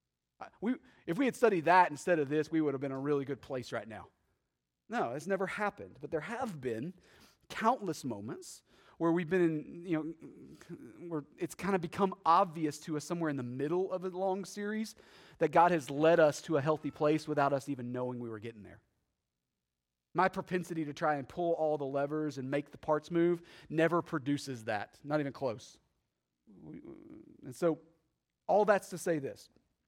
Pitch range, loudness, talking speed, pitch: 140-175 Hz, -33 LUFS, 195 wpm, 155 Hz